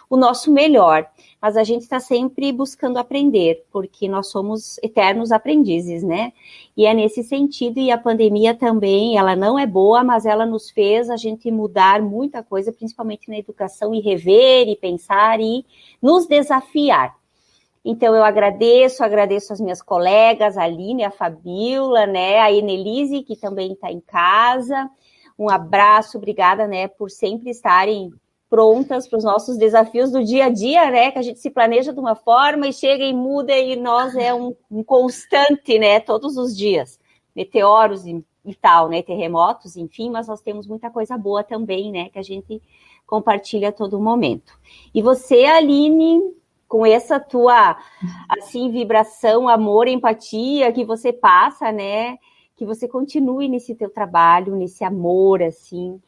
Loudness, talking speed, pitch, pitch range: -16 LUFS, 160 wpm, 225 Hz, 200-250 Hz